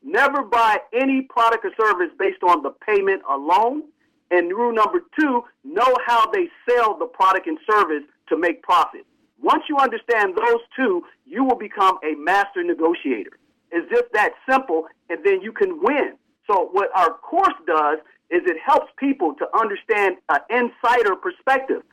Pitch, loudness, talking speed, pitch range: 270 Hz, -20 LUFS, 165 wpm, 220-365 Hz